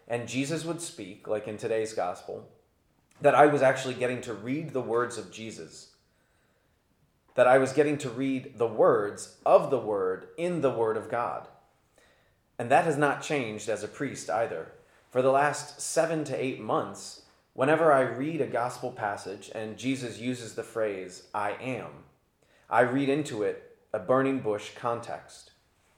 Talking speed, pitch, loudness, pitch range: 165 wpm, 130 Hz, -28 LUFS, 115-145 Hz